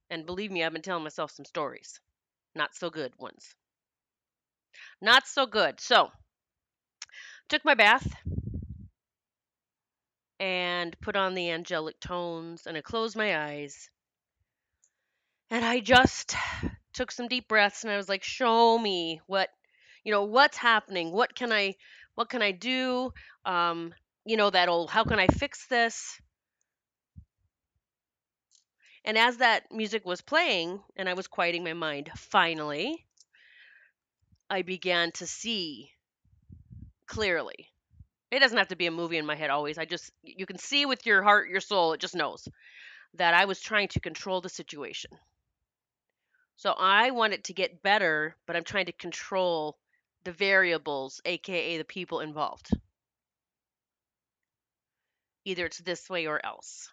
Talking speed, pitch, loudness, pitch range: 150 wpm, 190 Hz, -27 LUFS, 170-225 Hz